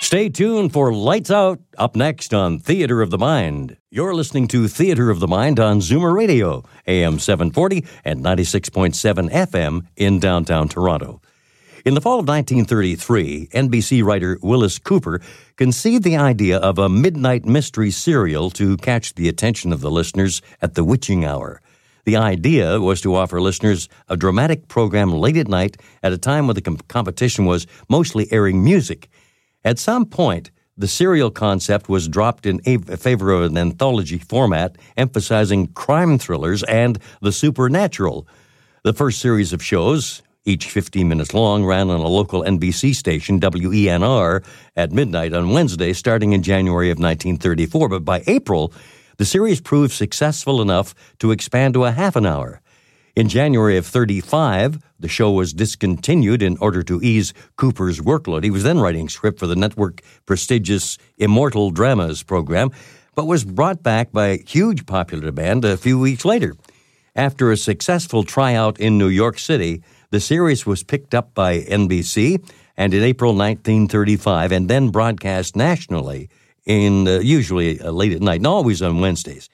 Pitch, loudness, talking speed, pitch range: 105 Hz, -18 LUFS, 160 wpm, 95-130 Hz